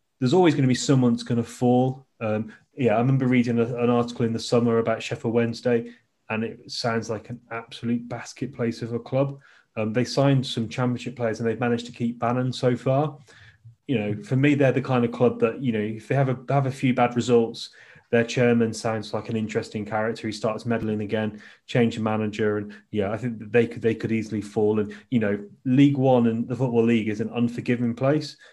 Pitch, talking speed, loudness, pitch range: 120 Hz, 225 wpm, -24 LUFS, 110-125 Hz